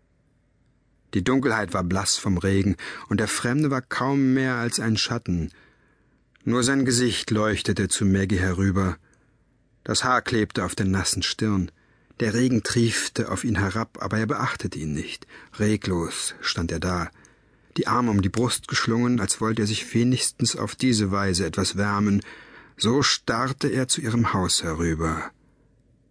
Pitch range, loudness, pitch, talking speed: 95-125 Hz, -24 LUFS, 110 Hz, 155 wpm